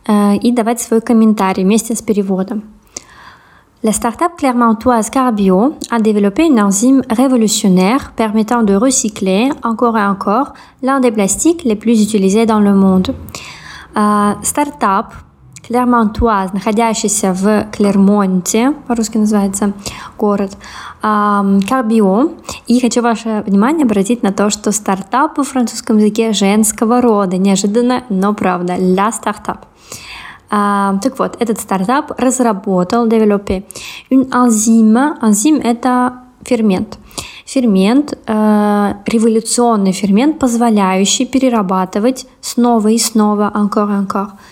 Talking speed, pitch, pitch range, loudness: 105 wpm, 220 Hz, 205-245 Hz, -13 LUFS